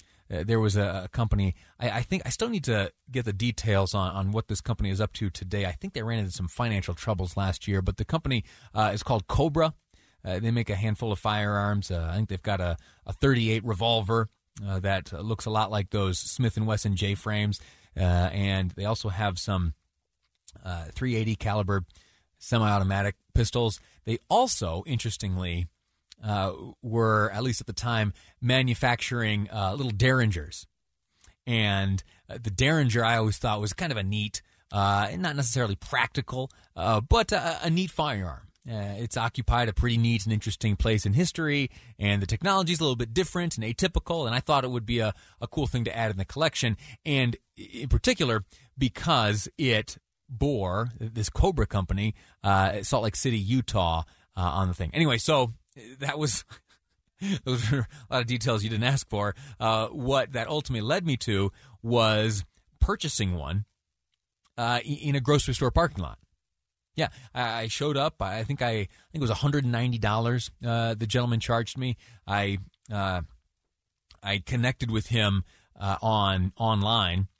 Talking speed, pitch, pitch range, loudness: 175 wpm, 110 Hz, 95-120 Hz, -27 LUFS